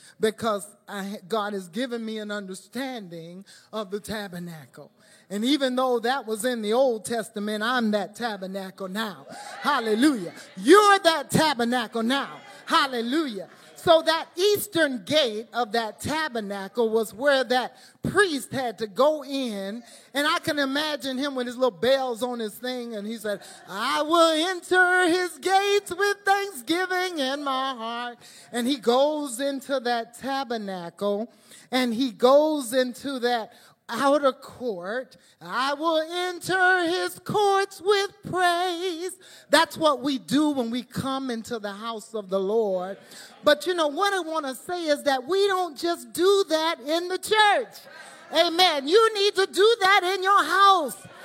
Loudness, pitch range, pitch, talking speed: -24 LUFS, 225-330 Hz, 265 Hz, 155 wpm